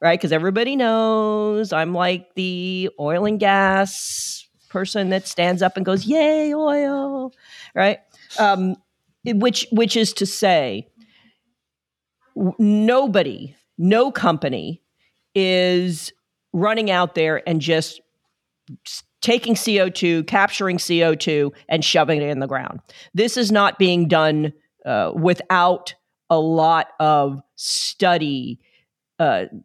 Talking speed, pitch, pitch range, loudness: 120 wpm, 185 Hz, 165-215 Hz, -19 LUFS